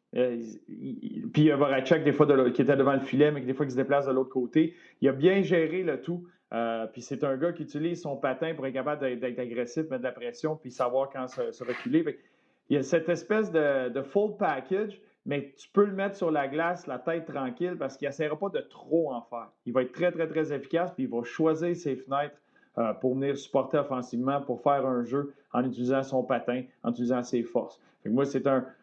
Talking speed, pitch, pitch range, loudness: 235 wpm, 140 Hz, 130-165 Hz, -29 LUFS